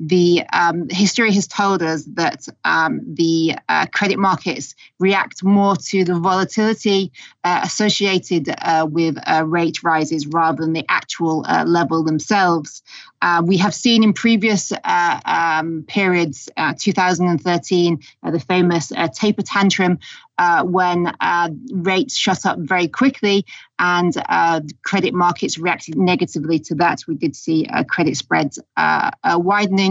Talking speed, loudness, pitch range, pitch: 145 wpm, -17 LUFS, 165-195 Hz, 175 Hz